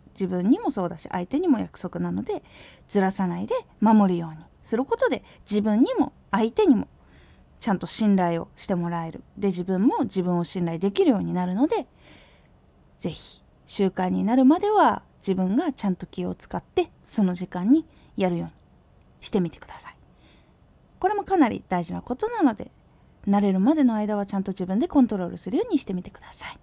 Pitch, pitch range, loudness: 205 Hz, 185-280 Hz, -24 LUFS